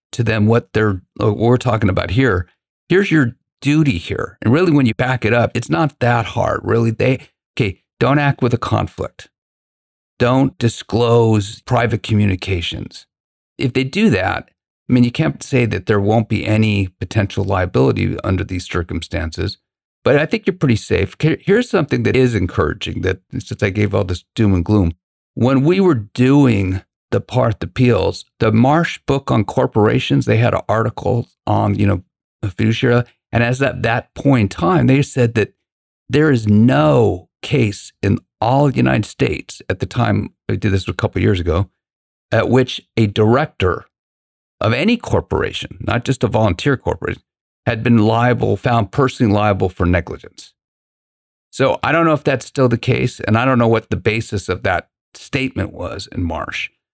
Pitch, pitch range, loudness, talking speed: 115 Hz, 100-130 Hz, -17 LUFS, 175 wpm